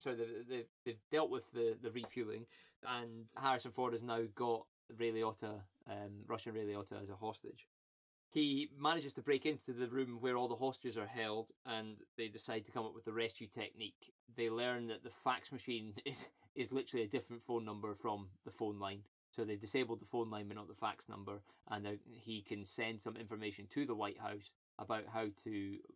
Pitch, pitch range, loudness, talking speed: 115 Hz, 105-125 Hz, -43 LUFS, 195 wpm